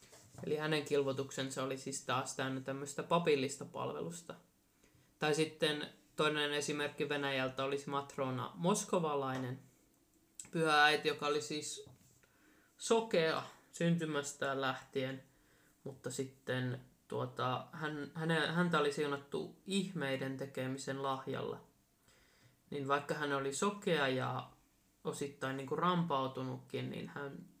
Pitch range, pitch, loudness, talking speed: 130-155 Hz, 140 Hz, -37 LUFS, 100 wpm